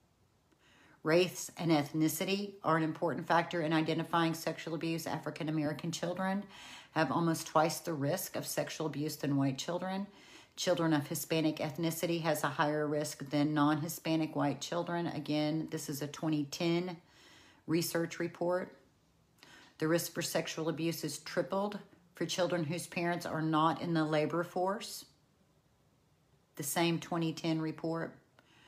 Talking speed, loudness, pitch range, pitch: 135 wpm, -34 LUFS, 155-170 Hz, 165 Hz